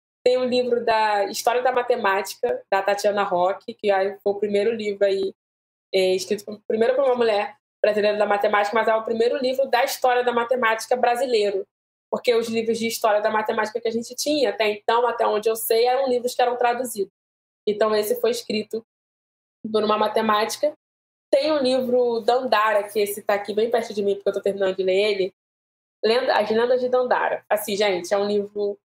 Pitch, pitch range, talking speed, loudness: 220 Hz, 205-240 Hz, 200 wpm, -22 LUFS